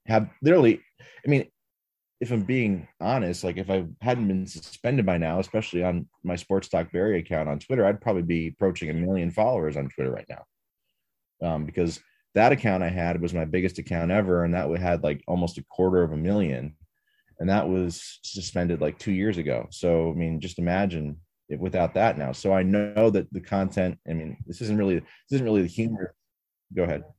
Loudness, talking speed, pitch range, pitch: -26 LUFS, 205 wpm, 85-100 Hz, 90 Hz